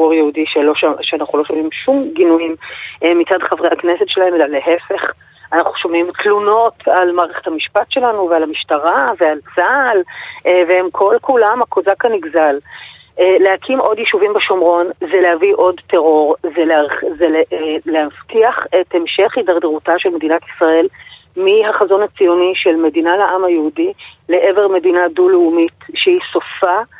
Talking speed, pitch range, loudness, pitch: 125 wpm, 165-220 Hz, -13 LUFS, 180 Hz